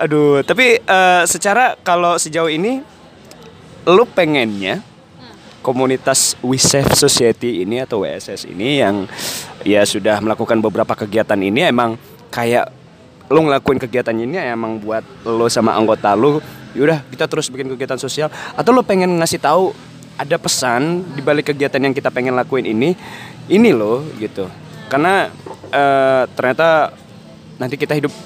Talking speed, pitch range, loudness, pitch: 140 wpm, 120-160 Hz, -15 LUFS, 135 Hz